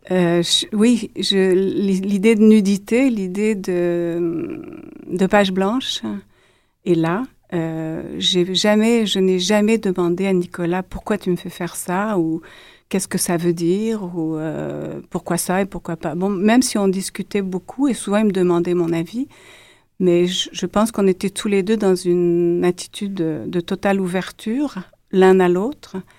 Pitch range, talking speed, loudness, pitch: 175-205 Hz, 170 wpm, -19 LUFS, 185 Hz